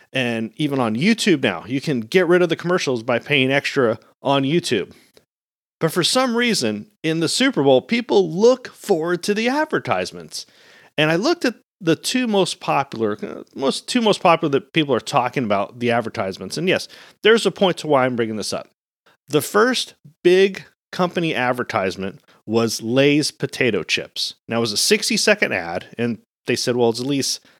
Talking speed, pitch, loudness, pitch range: 185 wpm, 160 Hz, -19 LUFS, 125-205 Hz